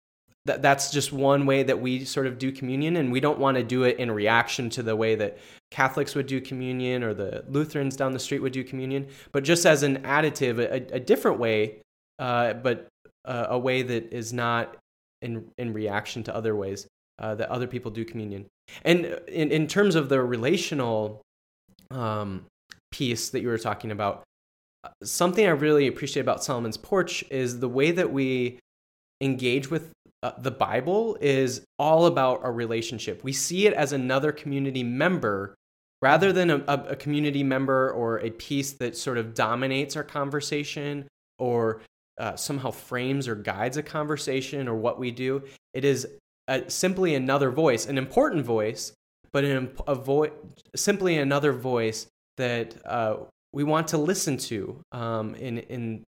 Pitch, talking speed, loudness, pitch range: 130 Hz, 175 wpm, -26 LUFS, 115-145 Hz